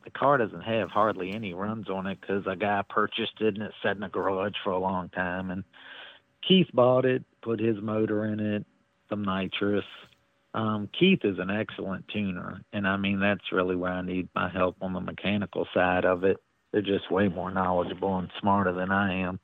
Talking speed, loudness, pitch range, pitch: 205 wpm, -28 LUFS, 90-105 Hz, 100 Hz